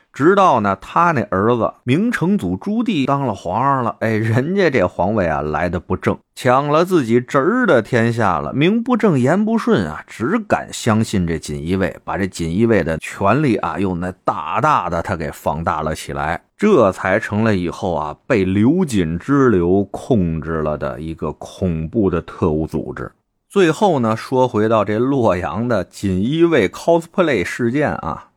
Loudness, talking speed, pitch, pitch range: -17 LUFS, 260 characters per minute, 110 Hz, 90-140 Hz